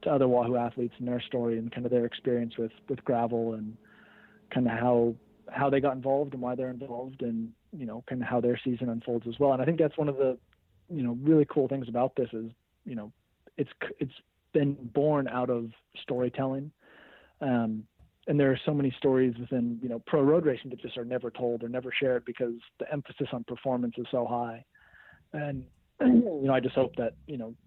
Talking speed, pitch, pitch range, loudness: 215 wpm, 125 Hz, 120-135 Hz, -30 LUFS